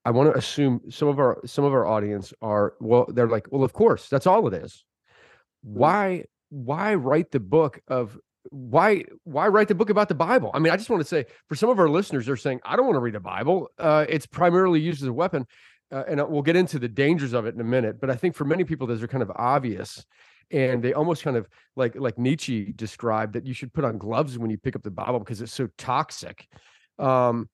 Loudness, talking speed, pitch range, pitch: -24 LUFS, 250 wpm, 120-160 Hz, 135 Hz